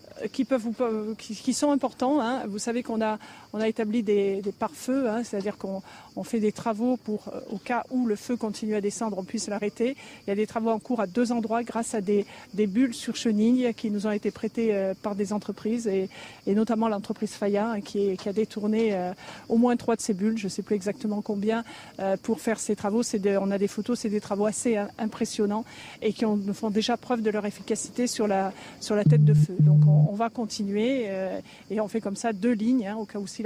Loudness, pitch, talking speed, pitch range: -27 LUFS, 220 Hz, 240 wpm, 205-230 Hz